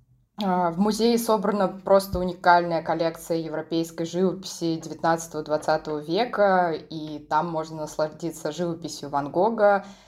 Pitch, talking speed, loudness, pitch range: 165 Hz, 100 wpm, -25 LUFS, 155-185 Hz